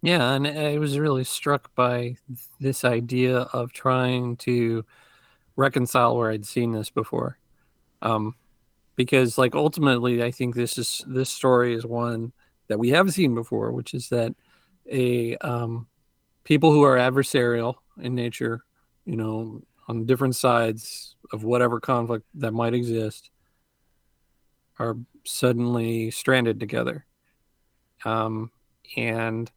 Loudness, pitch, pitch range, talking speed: -24 LUFS, 120 Hz, 115-130 Hz, 130 wpm